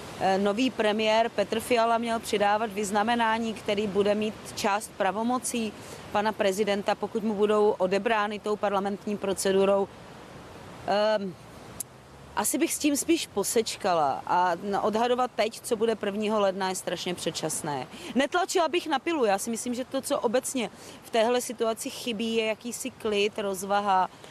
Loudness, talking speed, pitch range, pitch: -27 LUFS, 140 wpm, 200-235 Hz, 215 Hz